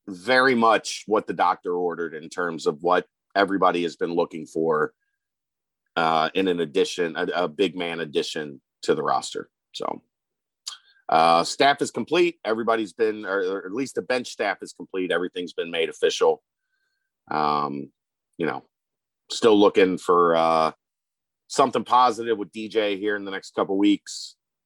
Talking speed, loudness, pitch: 160 wpm, -23 LUFS, 125 Hz